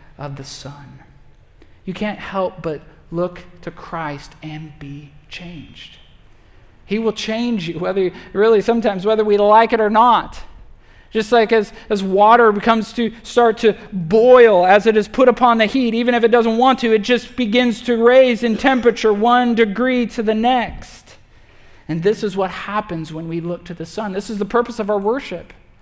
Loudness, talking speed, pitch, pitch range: -16 LUFS, 185 wpm, 215 Hz, 175-230 Hz